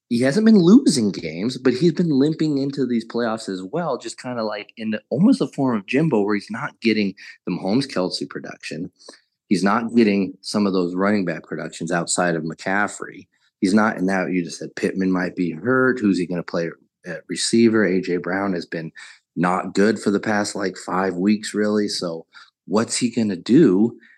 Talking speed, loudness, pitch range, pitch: 205 wpm, -20 LUFS, 90-120 Hz, 105 Hz